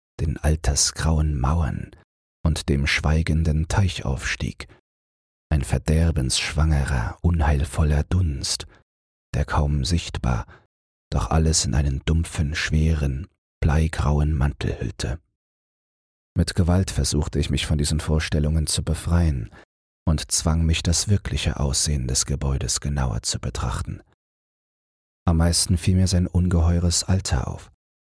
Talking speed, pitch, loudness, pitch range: 110 wpm, 75 Hz, -23 LUFS, 70-85 Hz